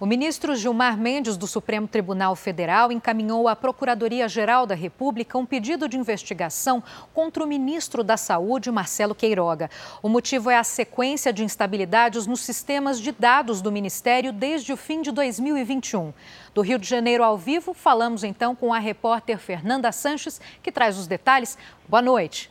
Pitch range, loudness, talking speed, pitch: 215-265 Hz, -23 LUFS, 165 wpm, 235 Hz